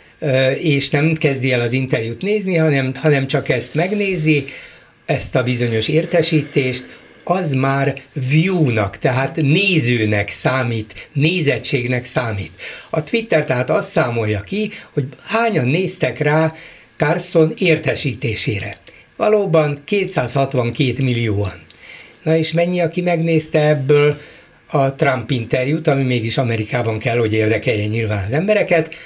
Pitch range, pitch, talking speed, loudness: 125-160 Hz, 145 Hz, 120 wpm, -17 LUFS